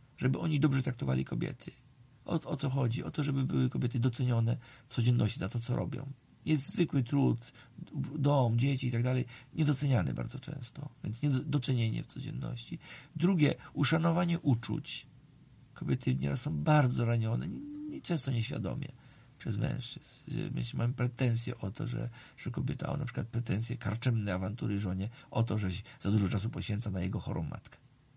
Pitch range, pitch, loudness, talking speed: 115-145 Hz, 130 Hz, -33 LUFS, 160 wpm